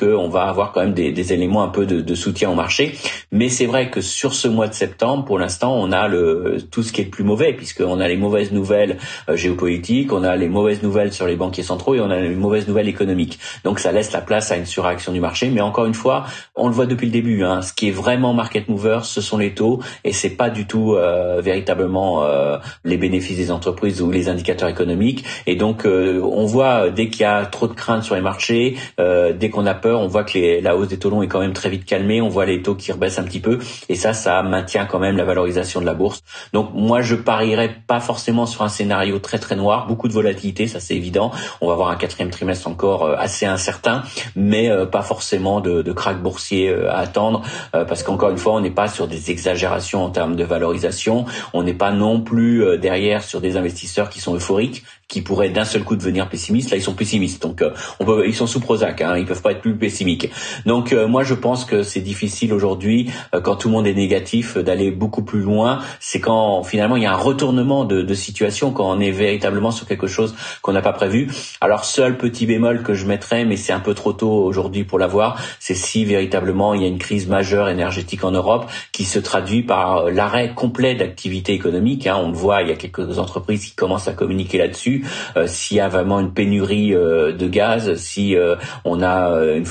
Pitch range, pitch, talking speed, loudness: 95-110 Hz, 100 Hz, 235 wpm, -18 LUFS